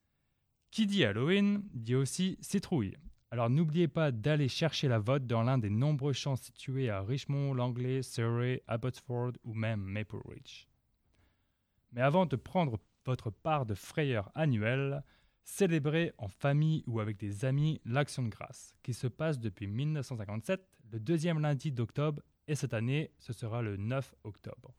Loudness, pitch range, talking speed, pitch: -34 LUFS, 115-150 Hz, 155 wpm, 130 Hz